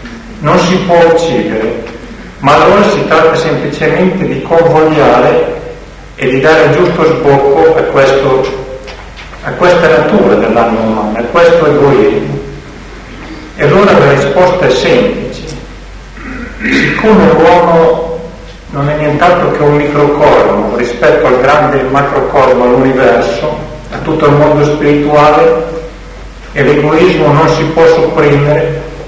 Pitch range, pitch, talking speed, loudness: 140-165 Hz, 150 Hz, 120 wpm, -8 LUFS